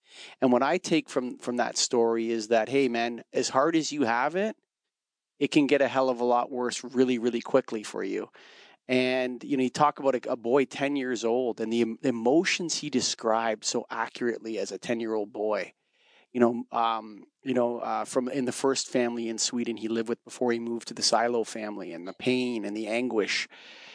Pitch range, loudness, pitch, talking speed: 115-130 Hz, -27 LUFS, 120 Hz, 215 wpm